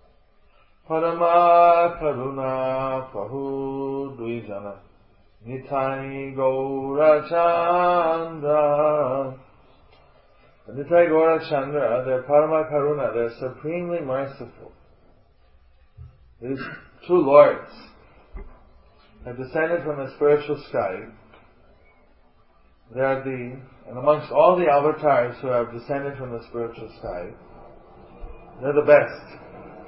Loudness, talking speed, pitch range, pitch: -21 LUFS, 80 wpm, 120-150 Hz, 135 Hz